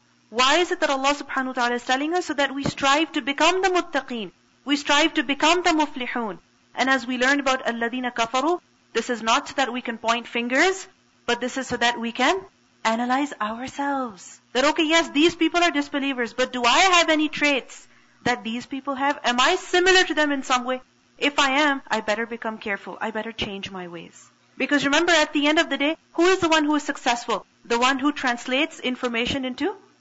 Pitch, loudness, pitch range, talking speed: 275 Hz, -22 LUFS, 240-305 Hz, 215 wpm